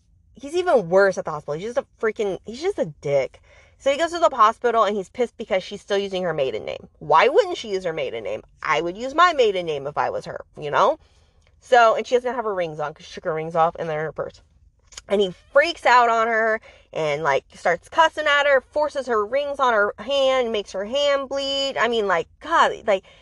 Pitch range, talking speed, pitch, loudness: 195-285 Hz, 245 wpm, 240 Hz, -21 LUFS